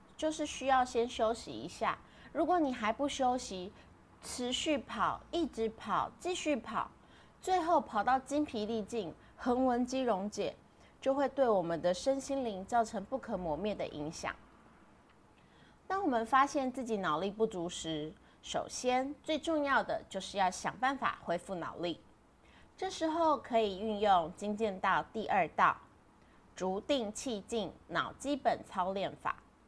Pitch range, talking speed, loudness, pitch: 195-275 Hz, 215 characters per minute, -35 LUFS, 235 Hz